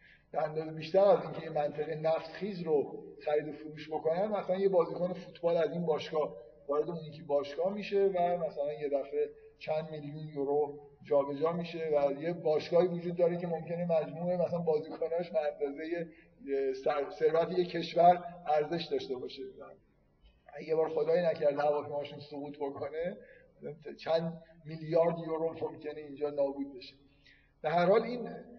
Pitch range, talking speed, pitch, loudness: 150-175 Hz, 145 wpm, 160 Hz, -33 LUFS